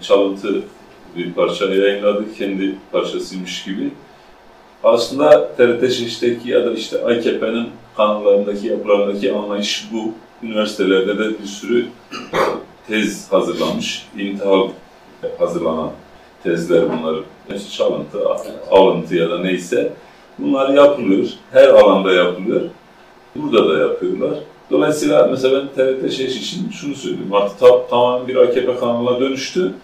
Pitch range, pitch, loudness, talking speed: 100-130 Hz, 110 Hz, -17 LUFS, 115 wpm